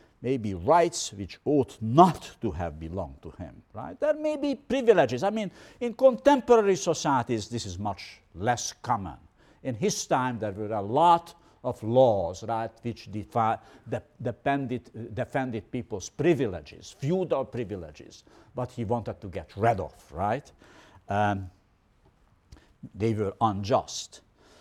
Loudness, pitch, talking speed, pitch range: -27 LUFS, 115 Hz, 140 wpm, 105-145 Hz